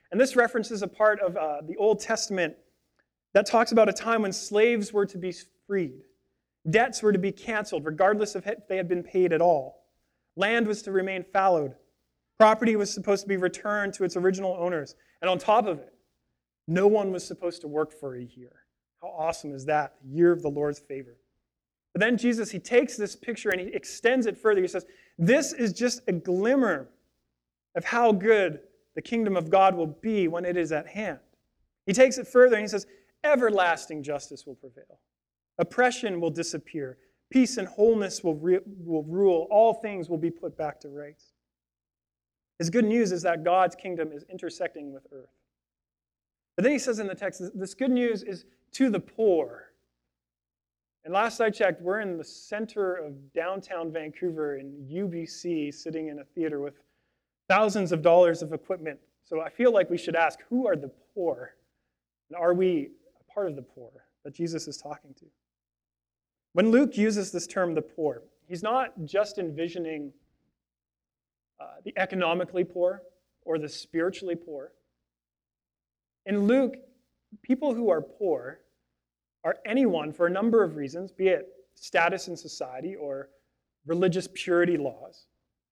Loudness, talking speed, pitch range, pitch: -26 LUFS, 175 wpm, 145-210 Hz, 175 Hz